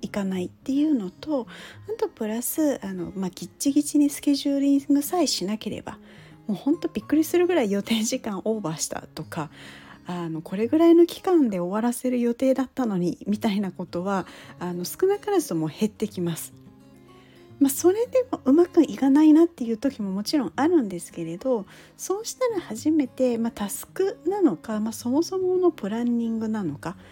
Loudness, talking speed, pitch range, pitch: -24 LUFS, 385 characters per minute, 195-305 Hz, 235 Hz